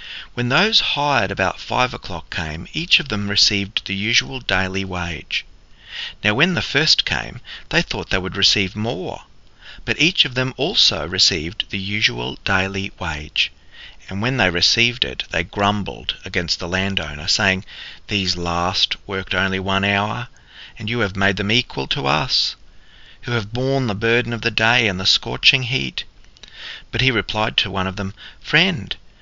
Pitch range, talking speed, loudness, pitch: 95-120 Hz, 165 wpm, -18 LUFS, 100 Hz